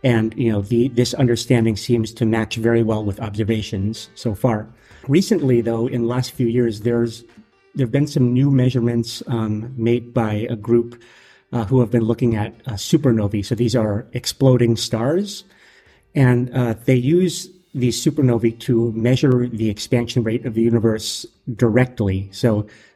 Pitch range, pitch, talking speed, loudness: 115-125 Hz, 120 Hz, 165 wpm, -19 LUFS